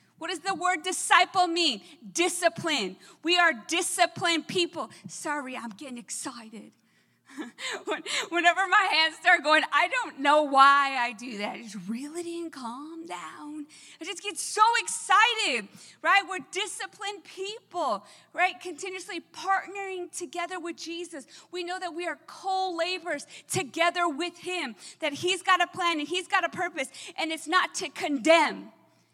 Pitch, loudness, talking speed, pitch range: 345 Hz, -26 LUFS, 150 wpm, 300-370 Hz